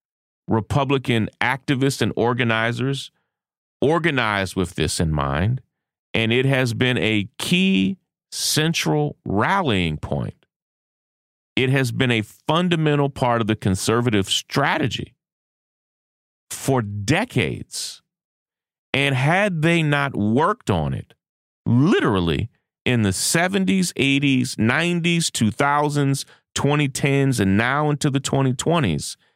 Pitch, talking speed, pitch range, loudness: 130 Hz, 100 wpm, 110-150 Hz, -20 LUFS